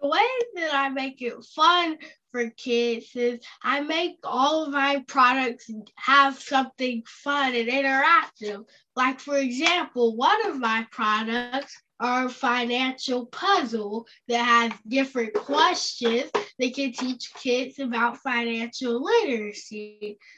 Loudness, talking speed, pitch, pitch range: -24 LUFS, 125 wpm, 255 Hz, 235-280 Hz